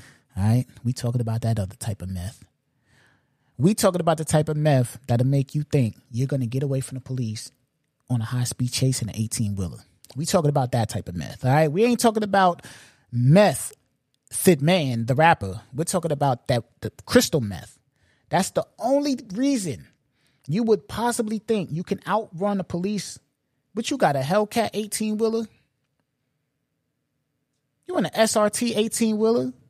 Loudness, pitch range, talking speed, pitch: -23 LUFS, 125-195 Hz, 175 wpm, 140 Hz